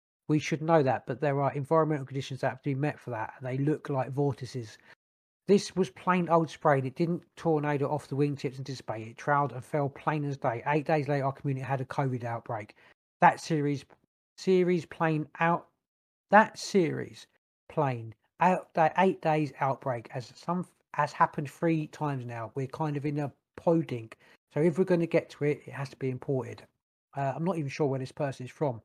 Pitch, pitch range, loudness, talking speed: 145 Hz, 130-160 Hz, -30 LUFS, 205 wpm